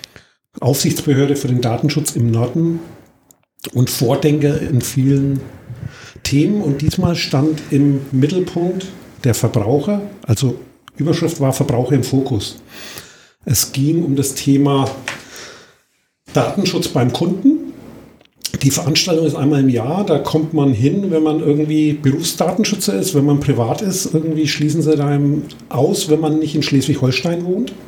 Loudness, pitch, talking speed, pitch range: -16 LUFS, 145 Hz, 135 wpm, 135-160 Hz